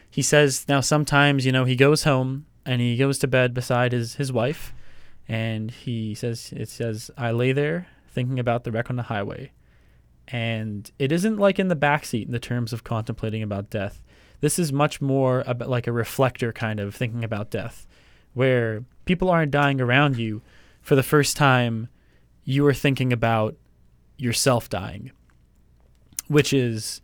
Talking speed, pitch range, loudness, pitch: 175 wpm, 110-140 Hz, -23 LUFS, 125 Hz